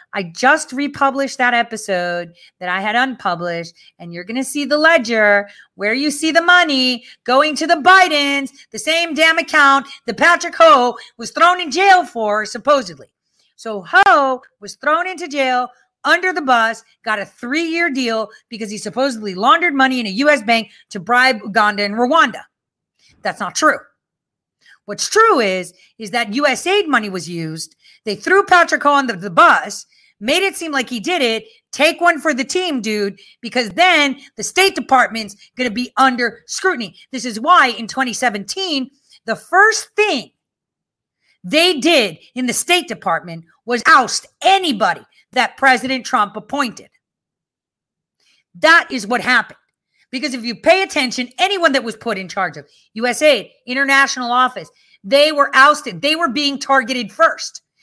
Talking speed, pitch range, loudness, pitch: 160 wpm, 225-315 Hz, -15 LUFS, 265 Hz